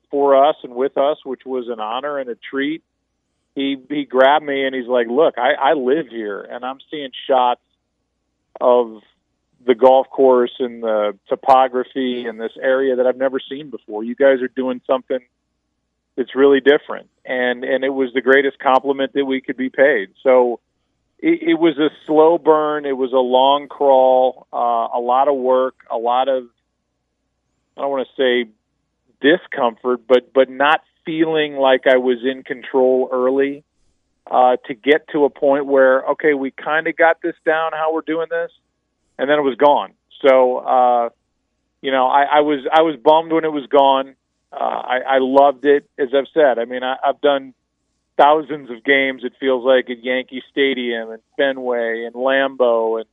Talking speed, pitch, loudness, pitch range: 185 wpm, 130 Hz, -17 LUFS, 125-140 Hz